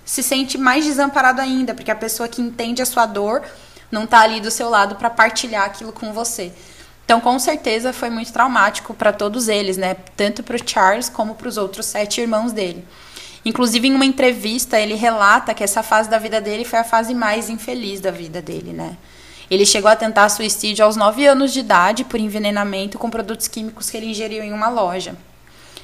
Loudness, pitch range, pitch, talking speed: -17 LUFS, 210-240 Hz, 225 Hz, 200 wpm